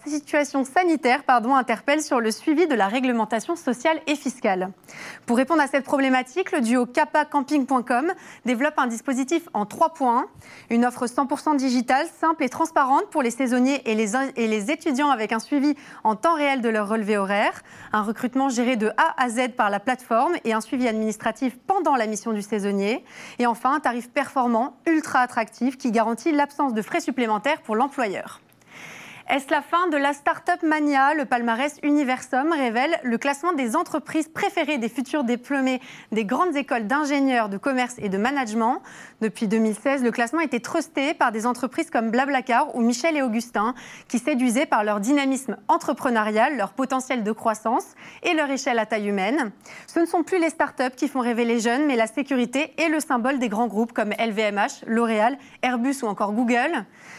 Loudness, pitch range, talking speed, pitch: -23 LUFS, 230-295 Hz, 180 wpm, 260 Hz